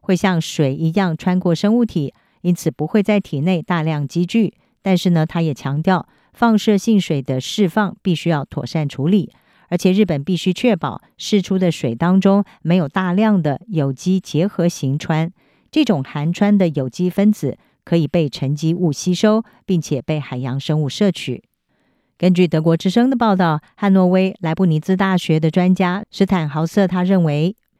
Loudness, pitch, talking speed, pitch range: -18 LUFS, 180 Hz, 260 characters per minute, 155-195 Hz